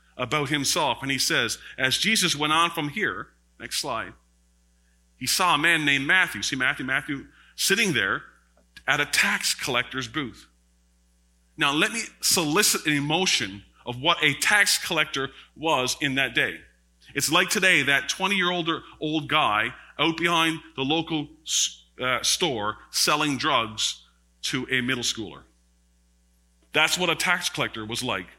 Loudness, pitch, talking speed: -23 LUFS, 135 Hz, 150 wpm